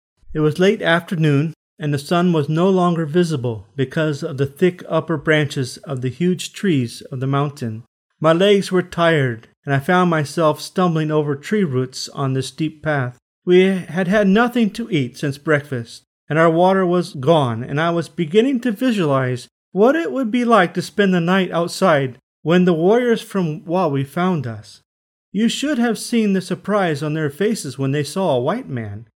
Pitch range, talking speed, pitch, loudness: 140-190 Hz, 185 wpm, 165 Hz, -18 LUFS